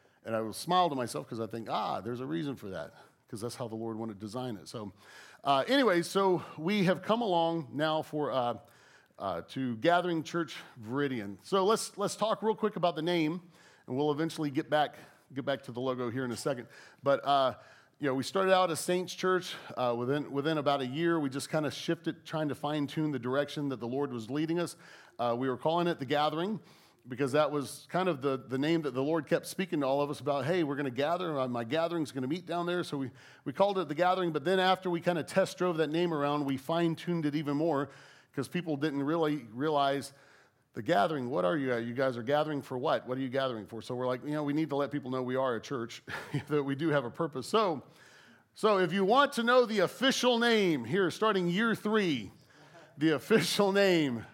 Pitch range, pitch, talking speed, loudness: 135-175 Hz, 150 Hz, 240 wpm, -31 LUFS